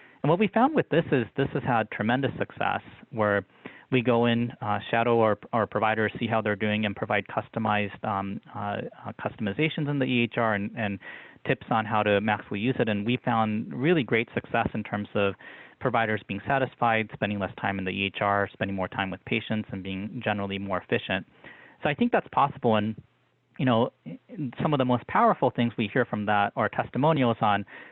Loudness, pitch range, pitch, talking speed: -27 LUFS, 105-125 Hz, 110 Hz, 200 wpm